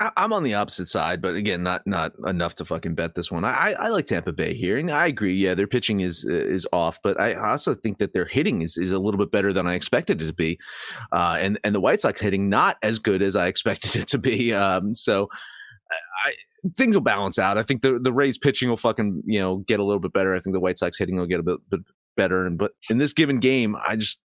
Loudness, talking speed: -23 LUFS, 265 wpm